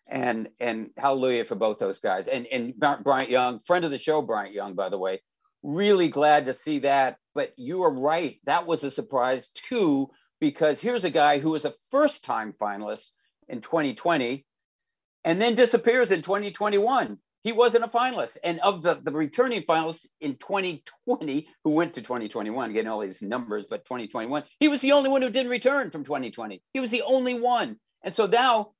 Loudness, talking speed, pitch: -25 LUFS, 190 wpm, 190 Hz